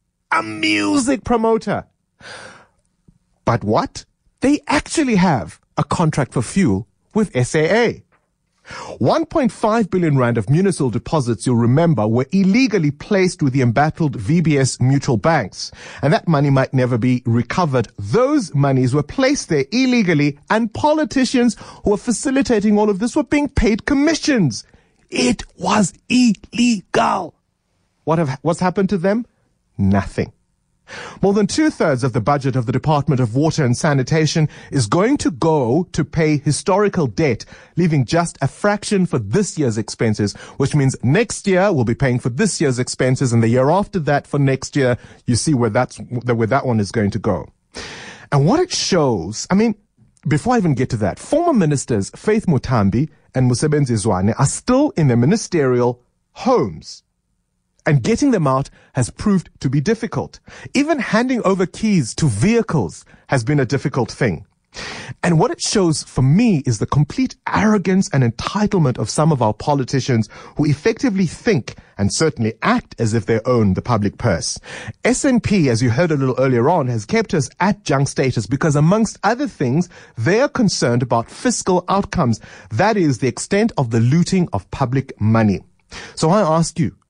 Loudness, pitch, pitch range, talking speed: -17 LUFS, 150 Hz, 125-205 Hz, 165 wpm